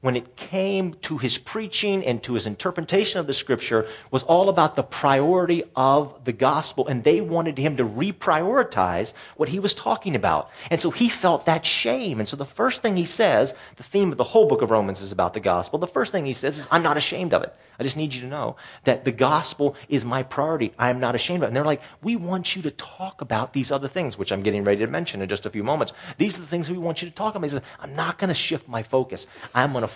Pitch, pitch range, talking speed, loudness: 150 Hz, 130-175 Hz, 260 wpm, -23 LUFS